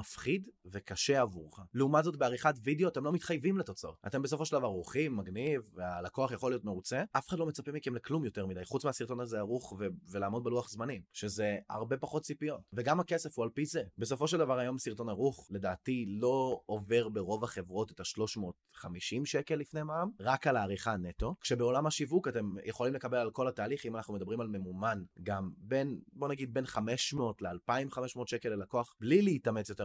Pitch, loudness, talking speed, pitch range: 125 Hz, -35 LUFS, 175 wpm, 105-140 Hz